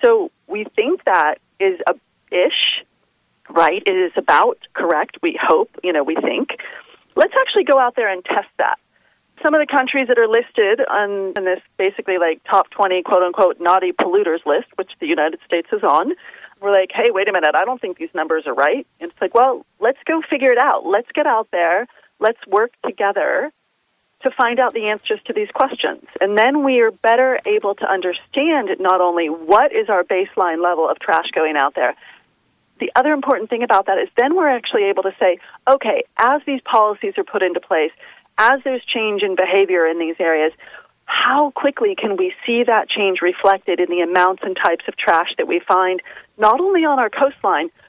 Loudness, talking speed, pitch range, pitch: -17 LUFS, 200 wpm, 190-310 Hz, 235 Hz